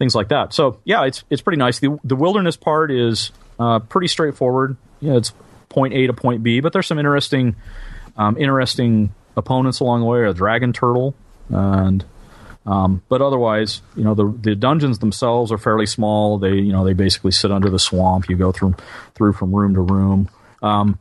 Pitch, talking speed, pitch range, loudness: 110 Hz, 195 wpm, 100-130 Hz, -18 LUFS